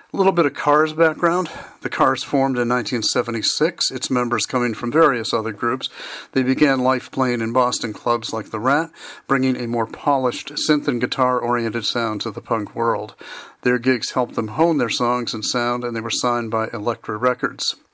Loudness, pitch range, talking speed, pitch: -20 LUFS, 120-135 Hz, 190 wpm, 125 Hz